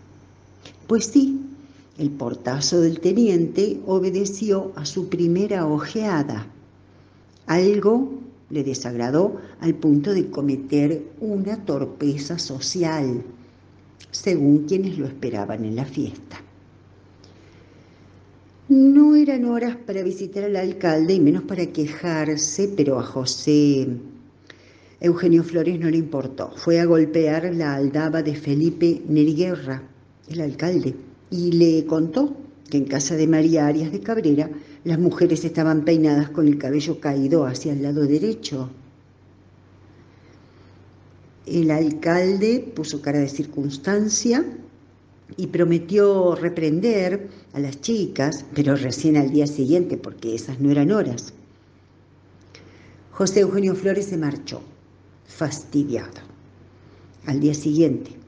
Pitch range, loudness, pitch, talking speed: 130-175 Hz, -21 LUFS, 150 Hz, 115 wpm